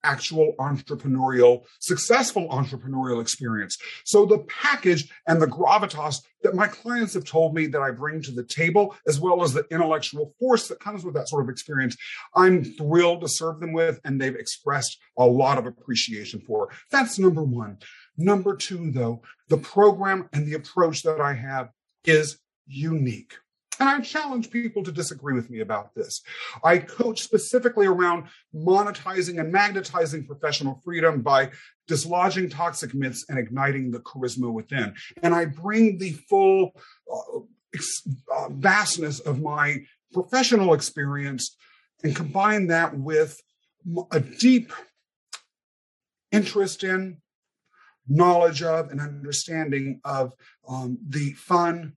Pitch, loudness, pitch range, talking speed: 160 Hz, -23 LUFS, 140-195 Hz, 145 wpm